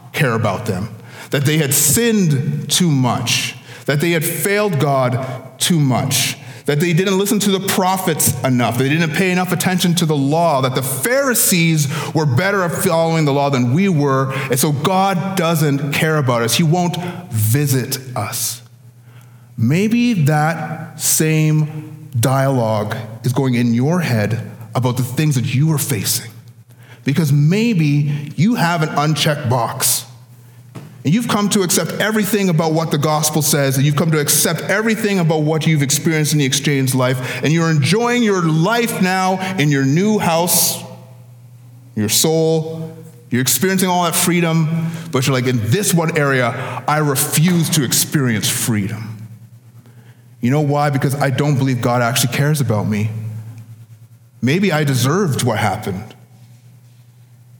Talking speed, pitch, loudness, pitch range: 155 wpm, 145 Hz, -16 LUFS, 125-165 Hz